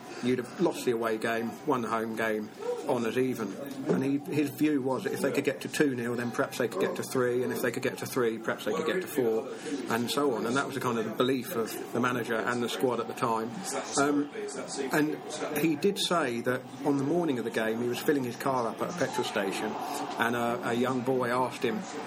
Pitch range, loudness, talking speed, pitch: 120-145 Hz, -30 LUFS, 255 wpm, 130 Hz